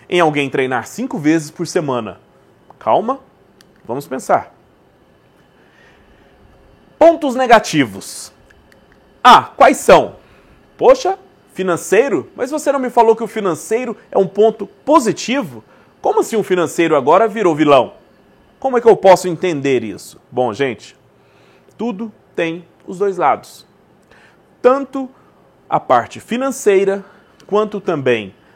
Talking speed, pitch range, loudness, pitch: 120 wpm, 160-240 Hz, -15 LUFS, 200 Hz